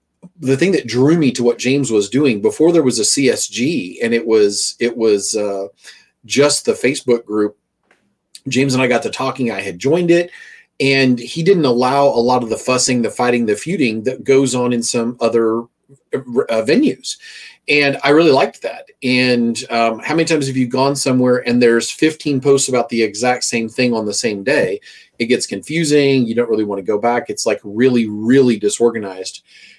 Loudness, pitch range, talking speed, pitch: -15 LUFS, 115-140 Hz, 195 wpm, 125 Hz